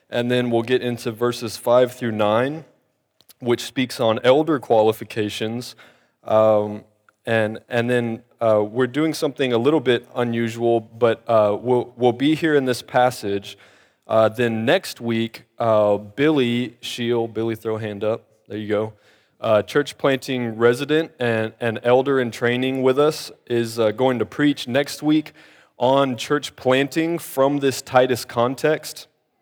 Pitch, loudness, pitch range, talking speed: 120 Hz, -21 LUFS, 115-135 Hz, 155 wpm